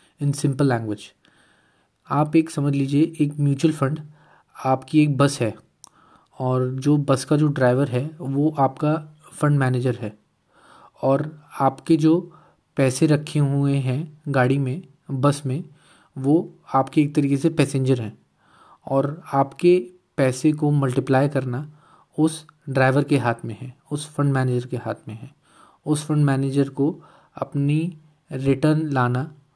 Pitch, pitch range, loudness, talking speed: 140 Hz, 135-150 Hz, -22 LUFS, 140 wpm